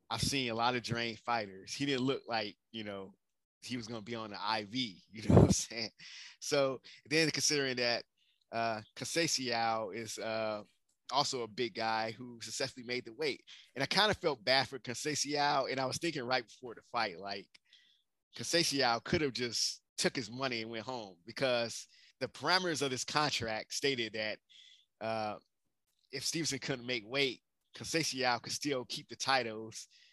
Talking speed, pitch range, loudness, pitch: 180 wpm, 110-135 Hz, -34 LUFS, 125 Hz